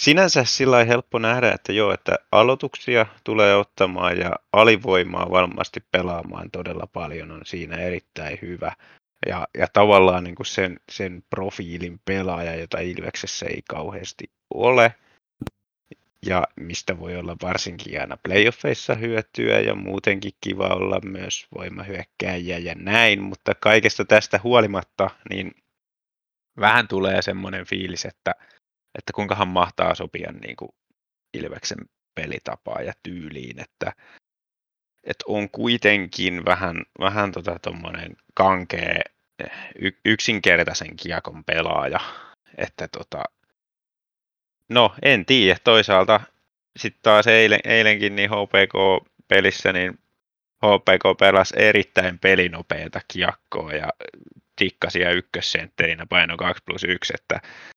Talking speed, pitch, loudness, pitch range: 110 wpm, 95 Hz, -20 LUFS, 90-110 Hz